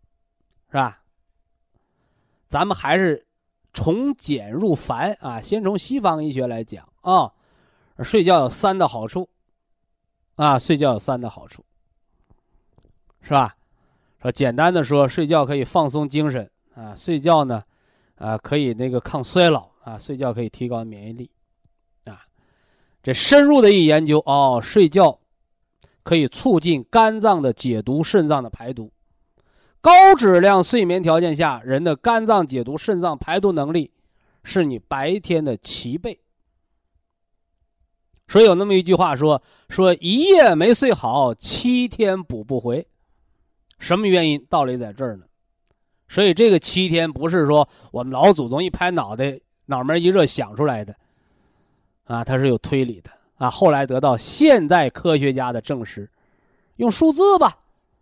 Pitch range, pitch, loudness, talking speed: 120-180 Hz, 145 Hz, -18 LUFS, 210 characters per minute